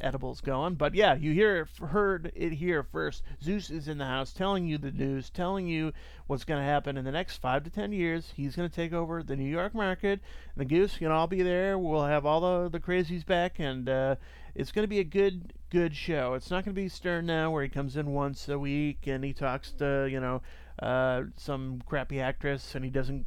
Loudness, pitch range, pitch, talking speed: -31 LUFS, 135-180 Hz, 155 Hz, 235 wpm